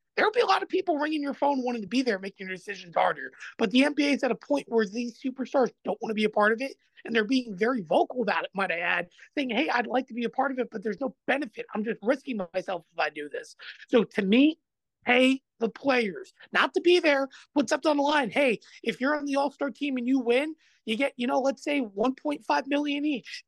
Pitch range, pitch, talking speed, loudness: 230-290 Hz, 265 Hz, 260 wpm, -27 LUFS